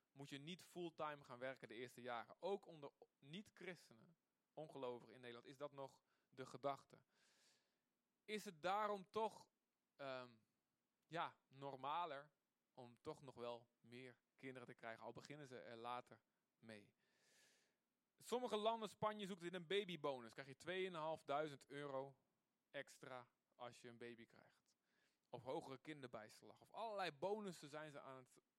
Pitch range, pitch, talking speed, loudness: 125-175 Hz, 140 Hz, 145 wpm, -52 LUFS